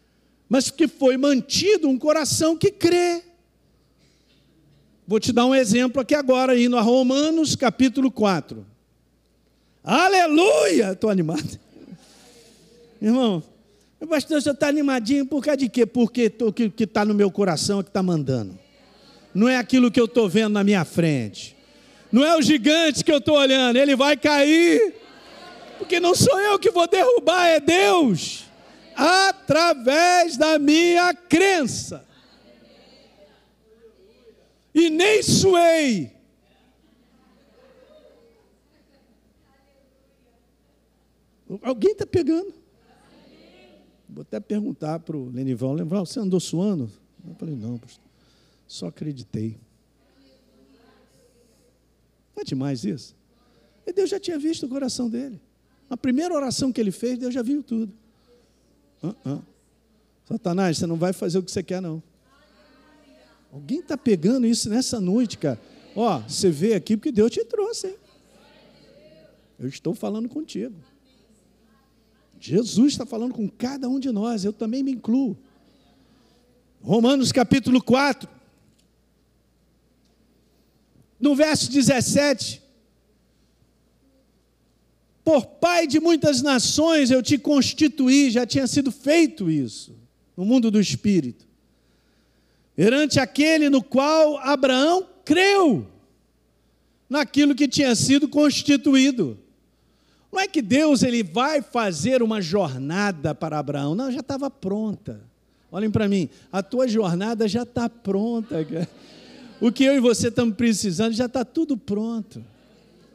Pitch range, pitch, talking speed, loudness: 200-290 Hz, 245 Hz, 125 wpm, -20 LUFS